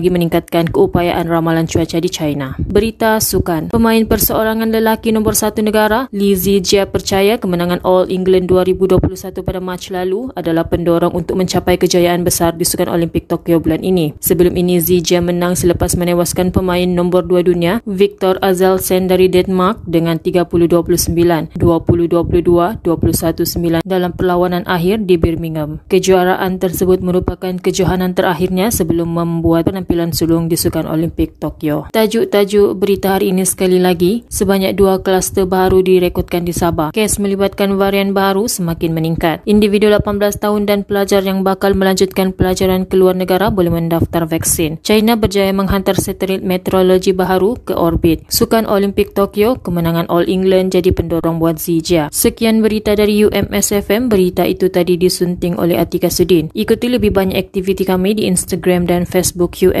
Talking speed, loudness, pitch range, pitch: 145 wpm, -14 LUFS, 175-195 Hz, 185 Hz